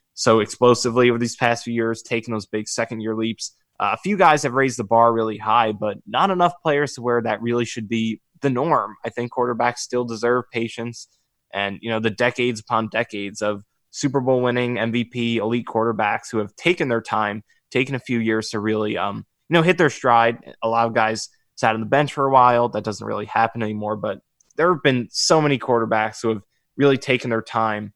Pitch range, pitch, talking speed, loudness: 110-125 Hz, 115 Hz, 215 wpm, -21 LUFS